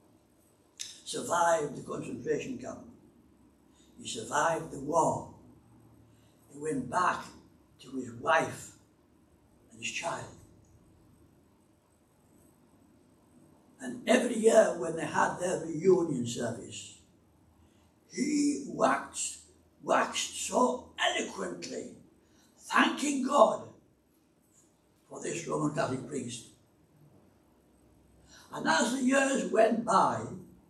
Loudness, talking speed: -30 LUFS, 85 wpm